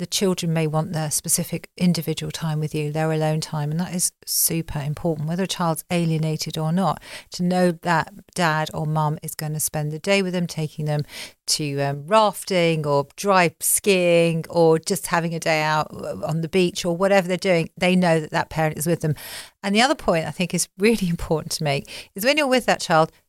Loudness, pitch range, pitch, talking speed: -22 LUFS, 155-180 Hz, 165 Hz, 215 wpm